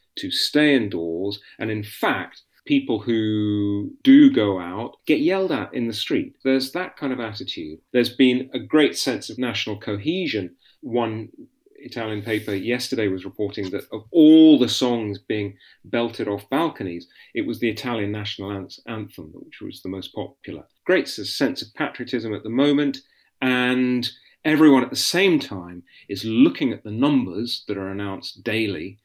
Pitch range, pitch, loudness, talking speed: 105-135 Hz, 120 Hz, -21 LUFS, 160 wpm